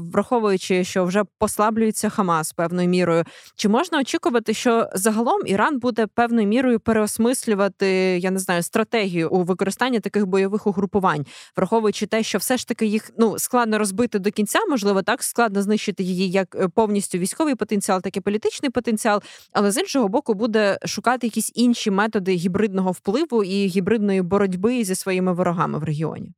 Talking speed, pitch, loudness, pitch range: 160 wpm, 210 Hz, -21 LUFS, 190-225 Hz